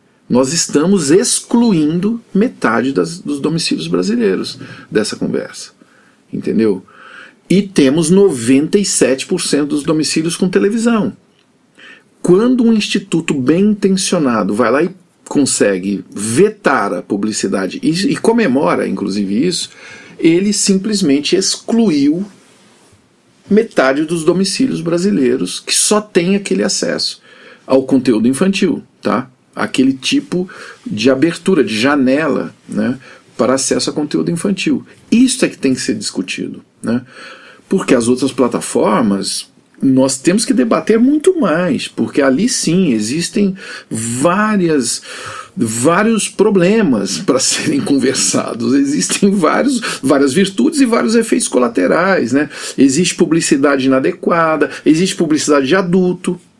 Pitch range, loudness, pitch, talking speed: 150-215 Hz, -14 LUFS, 185 Hz, 115 wpm